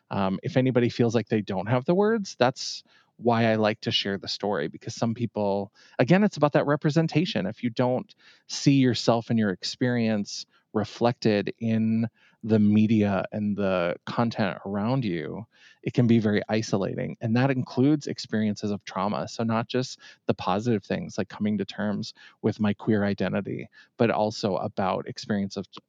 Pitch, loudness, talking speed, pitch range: 115 Hz, -26 LUFS, 170 wpm, 105-125 Hz